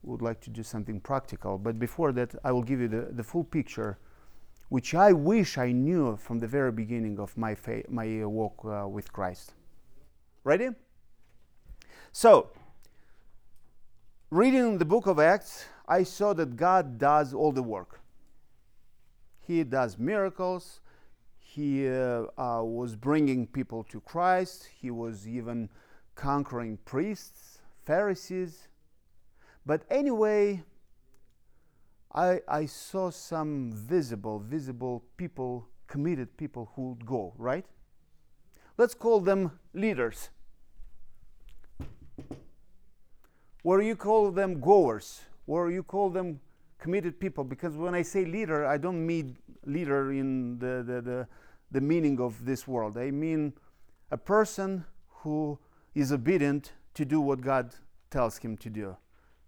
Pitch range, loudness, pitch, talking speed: 120-175 Hz, -29 LUFS, 140 Hz, 130 wpm